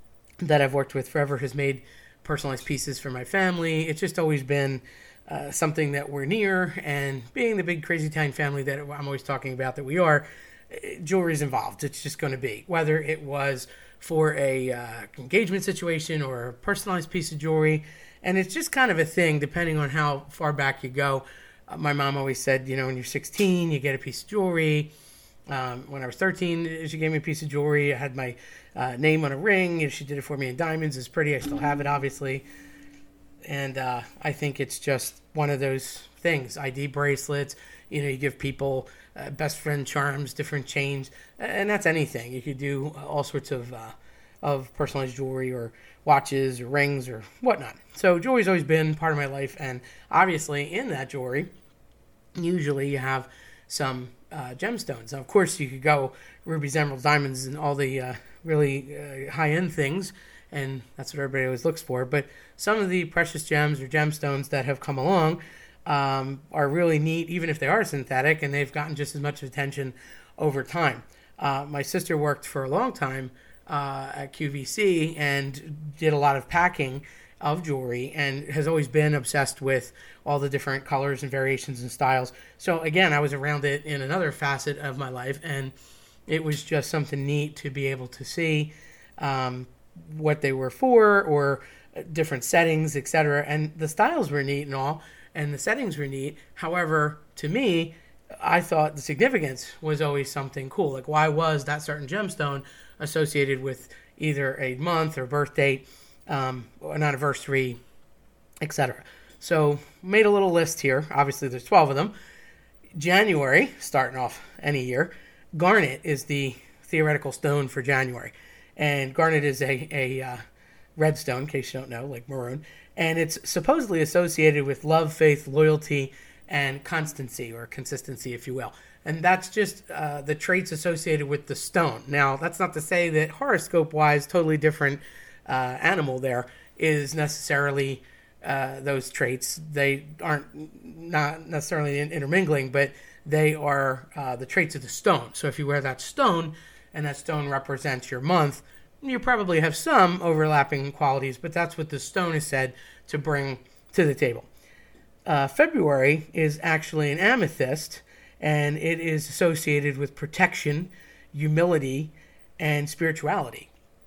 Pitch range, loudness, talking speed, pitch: 135-160 Hz, -26 LUFS, 175 wpm, 145 Hz